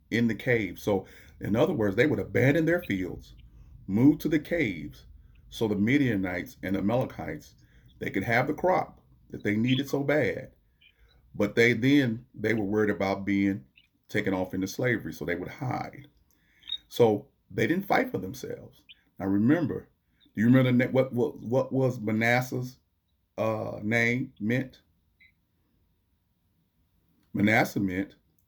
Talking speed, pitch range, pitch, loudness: 150 wpm, 90-125 Hz, 105 Hz, -27 LUFS